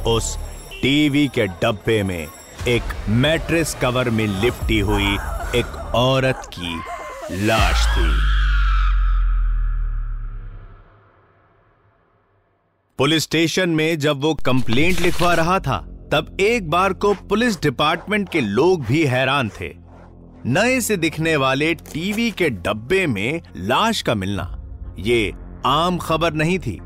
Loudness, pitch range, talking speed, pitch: -19 LUFS, 95-160 Hz, 115 wpm, 120 Hz